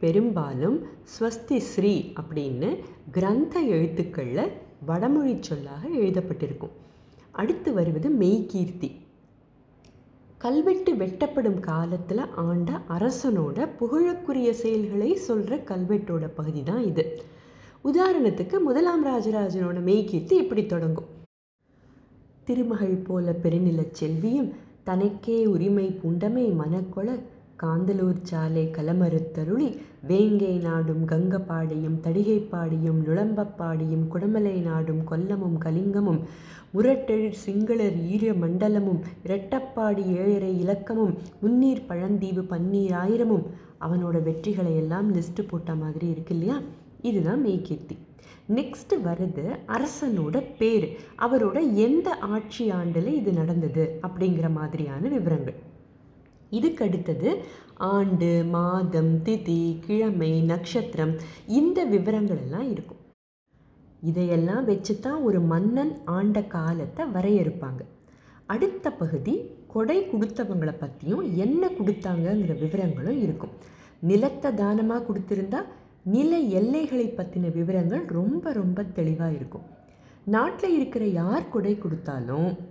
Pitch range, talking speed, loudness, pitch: 165-220 Hz, 90 wpm, -26 LUFS, 190 Hz